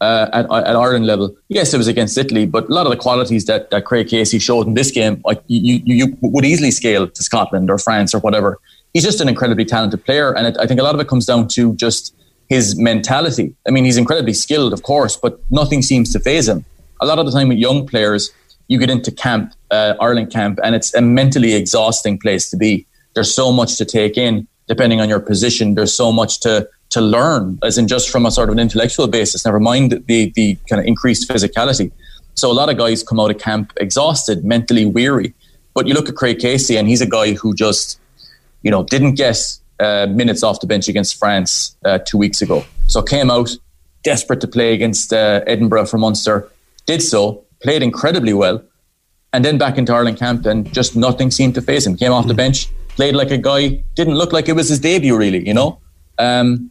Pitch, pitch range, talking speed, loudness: 115 Hz, 110-125 Hz, 225 wpm, -14 LUFS